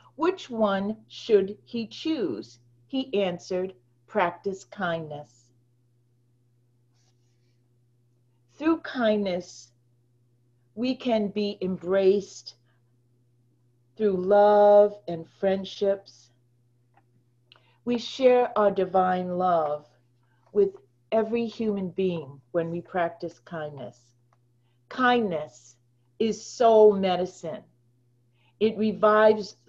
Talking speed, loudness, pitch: 75 wpm, -25 LUFS, 170 Hz